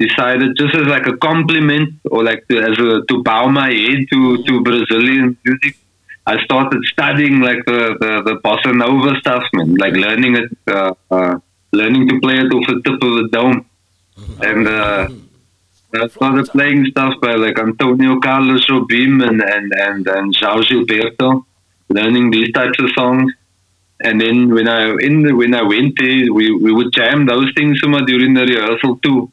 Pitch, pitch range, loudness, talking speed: 125 Hz, 110-130 Hz, -12 LUFS, 180 wpm